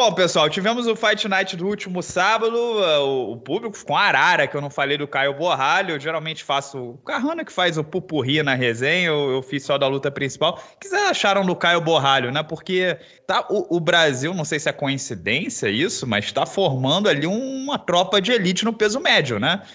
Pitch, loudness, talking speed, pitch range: 170 Hz, -20 LUFS, 215 wpm, 145-205 Hz